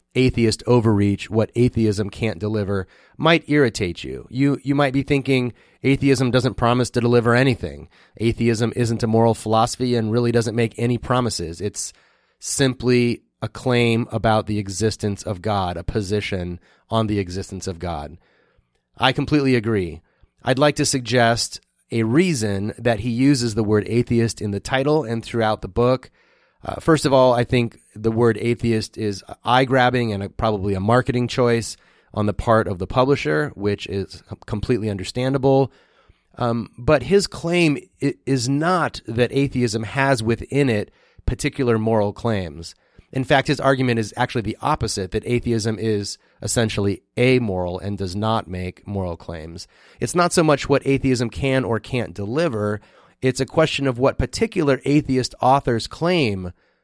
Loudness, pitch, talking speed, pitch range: -20 LUFS, 115 Hz, 155 wpm, 105-130 Hz